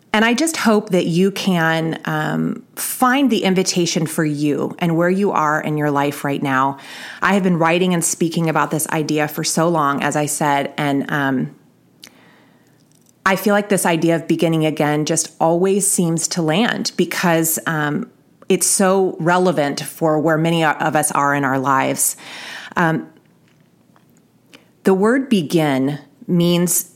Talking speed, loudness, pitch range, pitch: 160 wpm, -17 LUFS, 150-185 Hz, 165 Hz